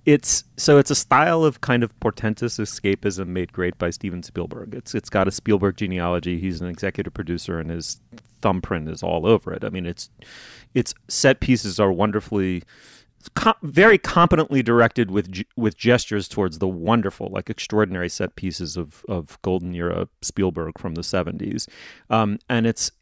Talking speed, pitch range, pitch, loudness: 170 wpm, 90-120 Hz, 100 Hz, -22 LUFS